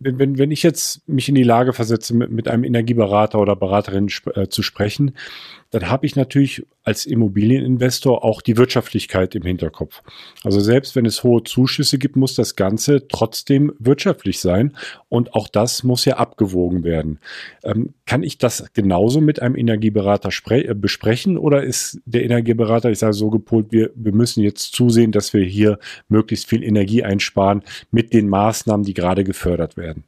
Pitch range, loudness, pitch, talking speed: 105-125 Hz, -17 LUFS, 115 Hz, 170 wpm